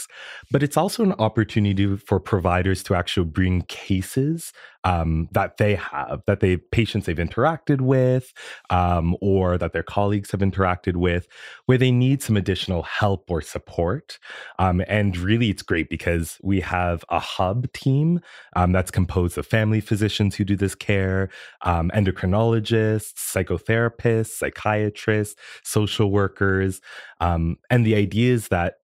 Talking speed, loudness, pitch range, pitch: 145 wpm, -22 LUFS, 90-110 Hz, 100 Hz